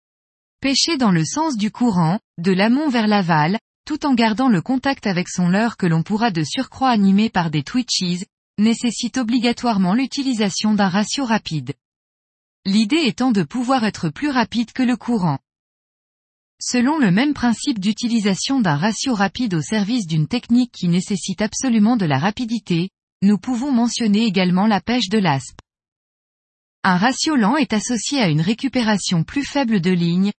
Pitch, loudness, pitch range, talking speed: 220 Hz, -19 LUFS, 185-250 Hz, 160 wpm